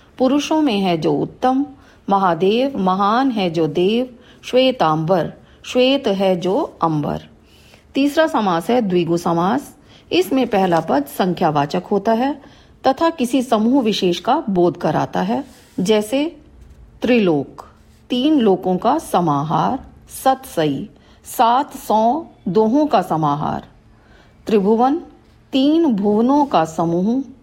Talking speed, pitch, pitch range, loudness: 115 wpm, 220 Hz, 180-265 Hz, -18 LUFS